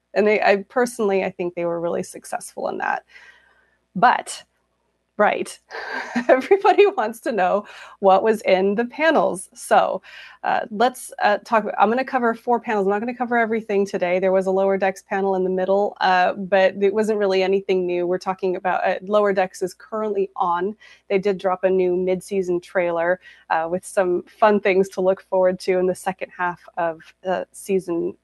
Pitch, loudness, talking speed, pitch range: 195 Hz, -21 LUFS, 195 wpm, 185-215 Hz